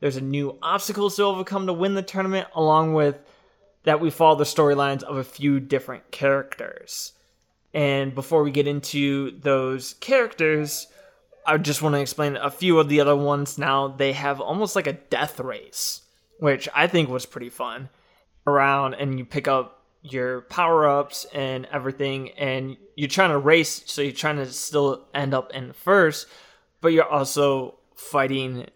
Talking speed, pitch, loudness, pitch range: 170 wpm, 145 Hz, -23 LUFS, 135-160 Hz